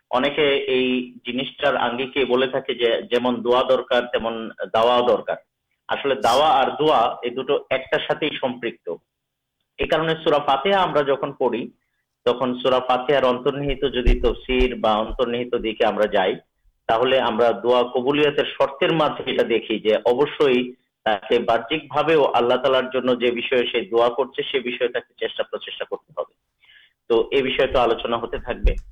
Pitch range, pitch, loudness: 120-145 Hz, 130 Hz, -21 LUFS